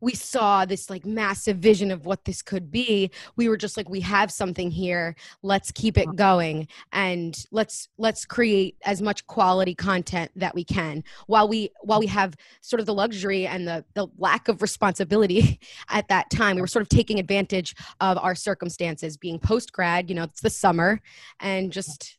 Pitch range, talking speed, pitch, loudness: 180-210 Hz, 190 wpm, 195 Hz, -24 LUFS